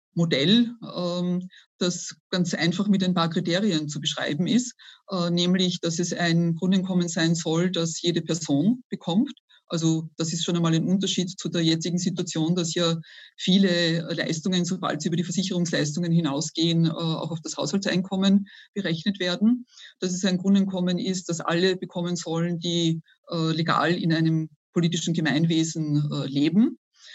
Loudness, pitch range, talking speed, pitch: -25 LUFS, 165-185 Hz, 145 wpm, 175 Hz